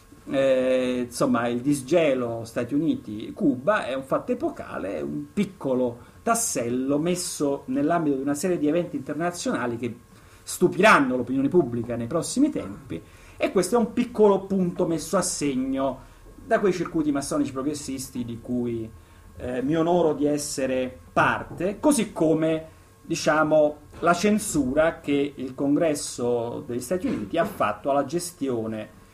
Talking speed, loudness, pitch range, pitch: 135 wpm, -25 LUFS, 125-180 Hz, 145 Hz